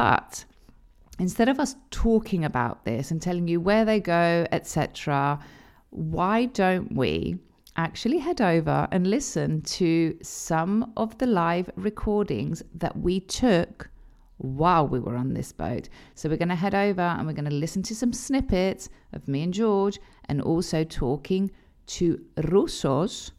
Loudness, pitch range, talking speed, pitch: -26 LUFS, 155-205 Hz, 155 wpm, 175 Hz